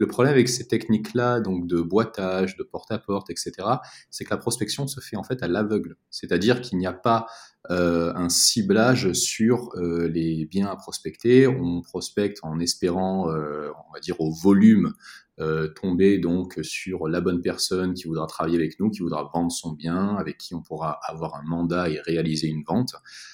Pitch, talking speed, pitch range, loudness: 90 Hz, 195 wpm, 85-105 Hz, -24 LUFS